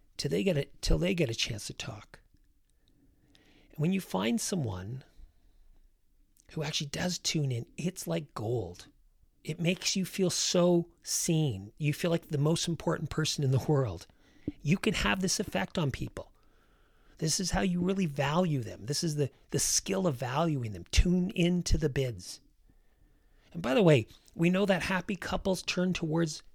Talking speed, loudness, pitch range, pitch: 175 wpm, -30 LUFS, 135-180 Hz, 165 Hz